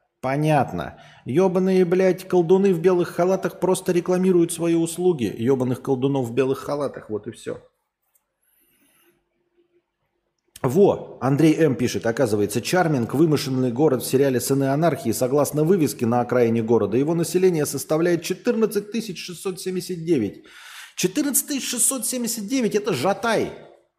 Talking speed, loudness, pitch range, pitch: 115 wpm, -21 LUFS, 135-190 Hz, 170 Hz